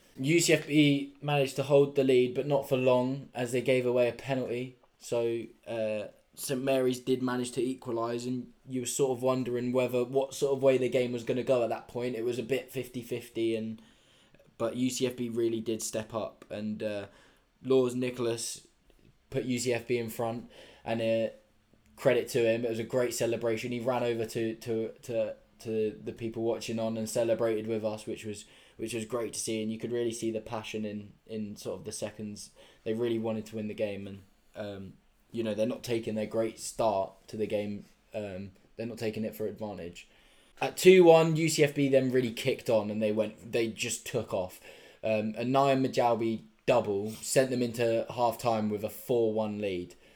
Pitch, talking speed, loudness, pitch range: 115 Hz, 195 wpm, -30 LUFS, 110-125 Hz